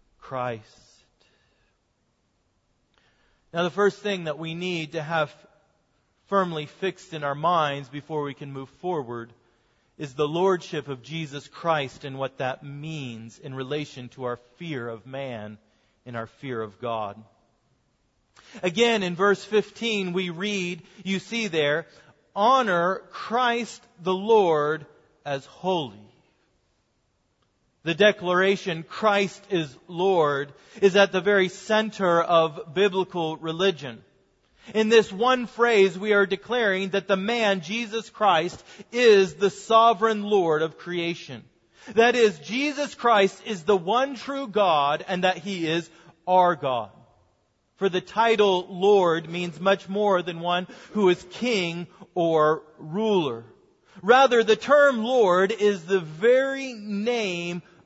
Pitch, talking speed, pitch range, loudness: 180 Hz, 130 wpm, 145-205 Hz, -24 LUFS